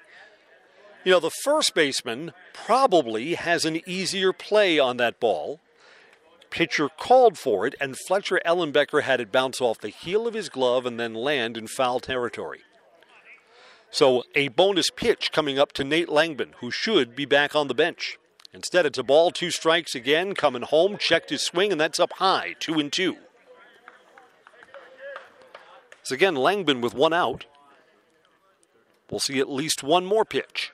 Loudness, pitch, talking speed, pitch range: -23 LUFS, 160 Hz, 160 wpm, 140-205 Hz